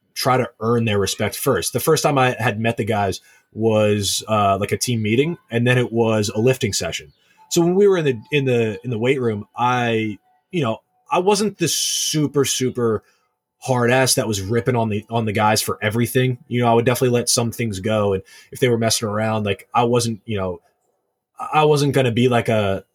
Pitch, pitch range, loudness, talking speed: 120 Hz, 110-130 Hz, -19 LUFS, 225 wpm